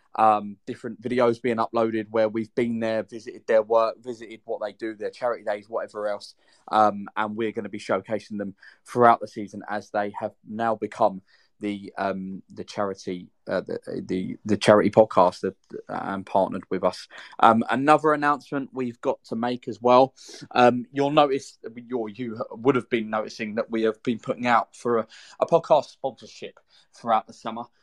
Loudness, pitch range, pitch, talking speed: -24 LUFS, 105-125 Hz, 115 Hz, 185 wpm